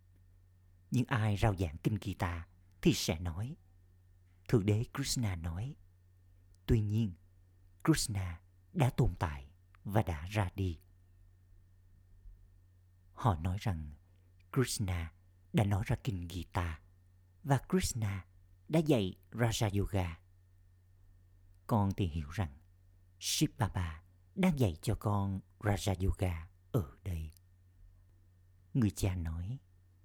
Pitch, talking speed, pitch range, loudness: 90 Hz, 110 wpm, 90-105 Hz, -35 LUFS